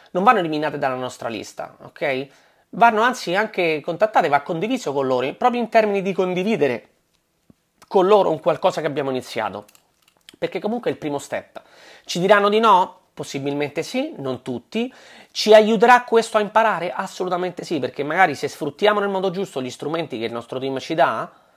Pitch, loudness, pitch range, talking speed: 180 Hz, -20 LUFS, 145-215 Hz, 175 wpm